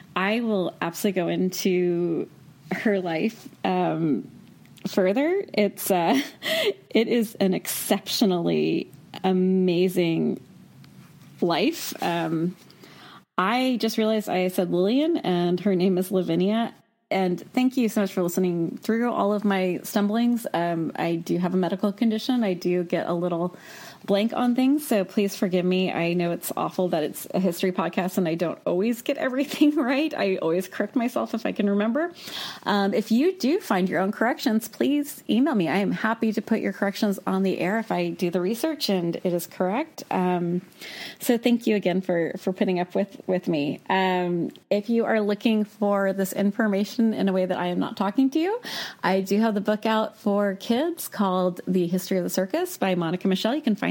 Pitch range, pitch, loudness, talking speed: 180-230 Hz, 195 Hz, -24 LUFS, 185 wpm